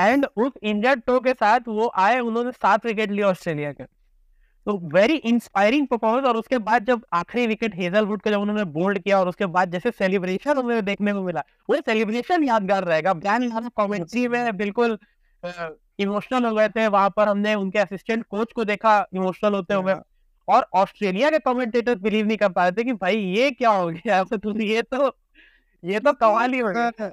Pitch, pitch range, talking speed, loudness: 215 Hz, 195-240 Hz, 120 wpm, -22 LUFS